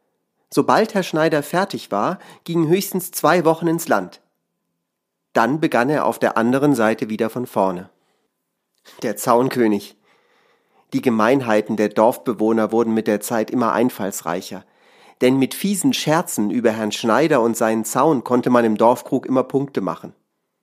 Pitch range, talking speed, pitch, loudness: 110-160 Hz, 145 wpm, 125 Hz, -19 LUFS